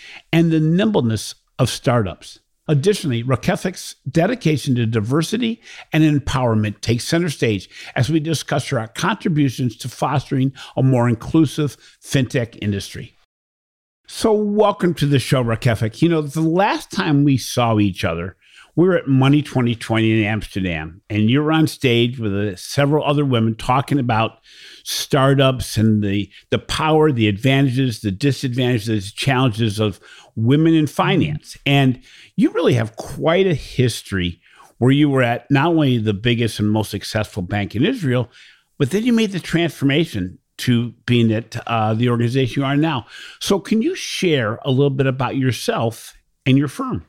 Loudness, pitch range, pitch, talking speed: -18 LUFS, 115-150 Hz, 130 Hz, 155 wpm